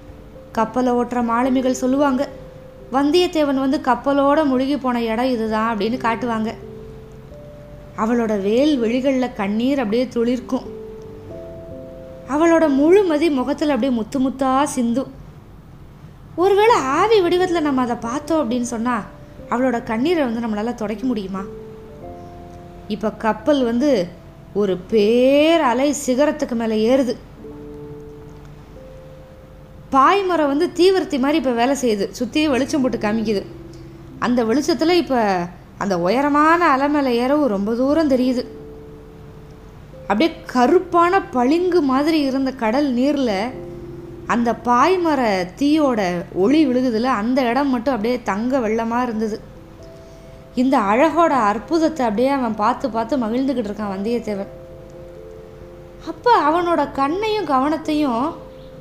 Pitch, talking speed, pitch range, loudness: 250 Hz, 105 wpm, 215-285 Hz, -18 LUFS